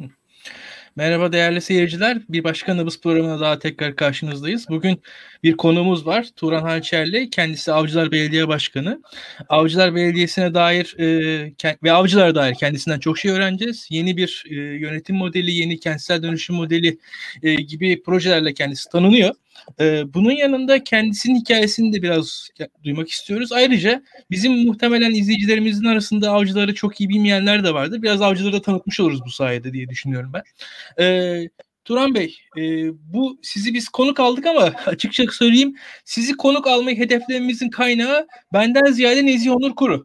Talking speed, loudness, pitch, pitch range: 140 wpm, -18 LUFS, 185 Hz, 160-230 Hz